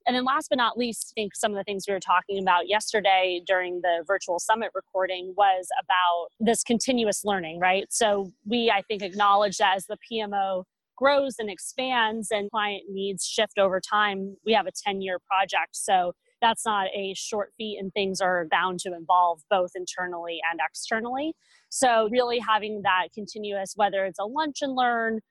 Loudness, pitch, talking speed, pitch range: -25 LUFS, 200 Hz, 185 wpm, 190-225 Hz